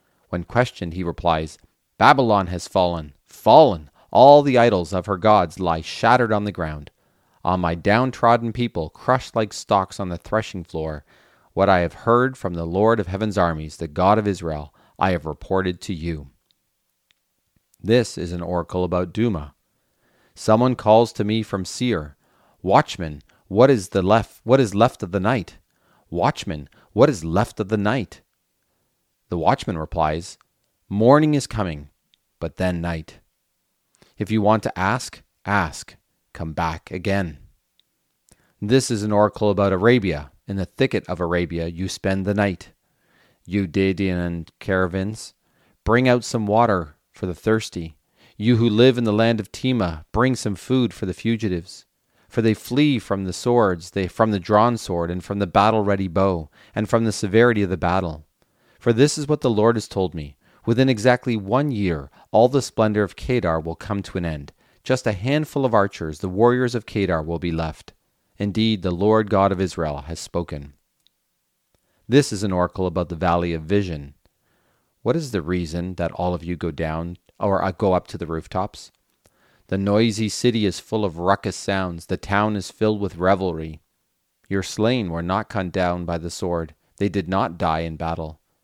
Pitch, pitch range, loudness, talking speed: 95 Hz, 85-110 Hz, -21 LUFS, 175 wpm